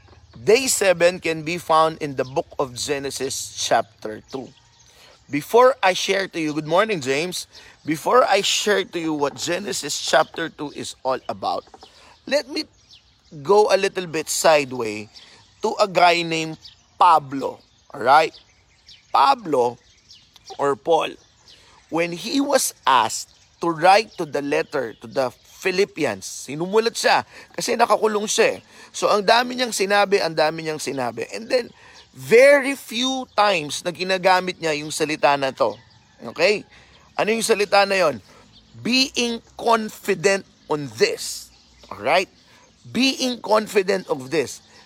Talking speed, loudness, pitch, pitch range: 135 wpm, -20 LUFS, 185 Hz, 155-225 Hz